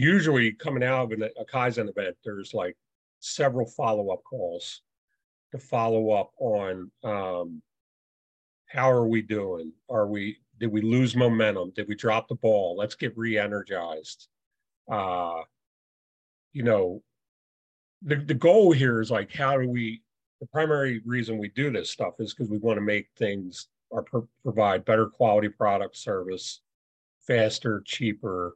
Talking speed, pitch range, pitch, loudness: 150 wpm, 105-130 Hz, 115 Hz, -26 LUFS